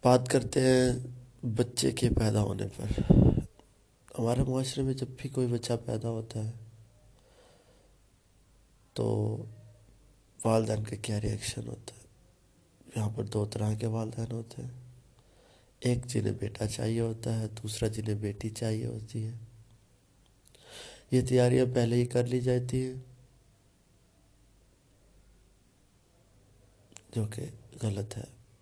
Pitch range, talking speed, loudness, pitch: 110-125 Hz, 120 wpm, -31 LUFS, 115 Hz